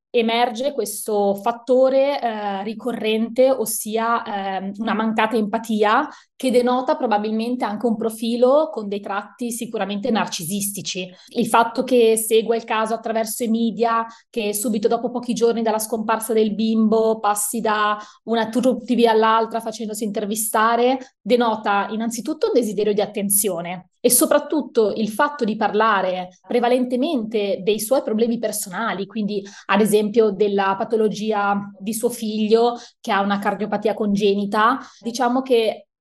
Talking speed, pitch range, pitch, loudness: 130 wpm, 210-235 Hz, 225 Hz, -20 LUFS